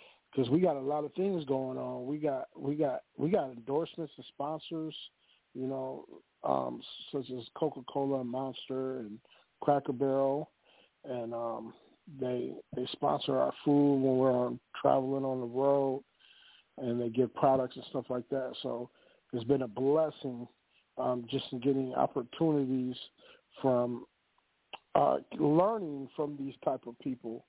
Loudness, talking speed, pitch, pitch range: -33 LUFS, 150 wpm, 130 Hz, 125-140 Hz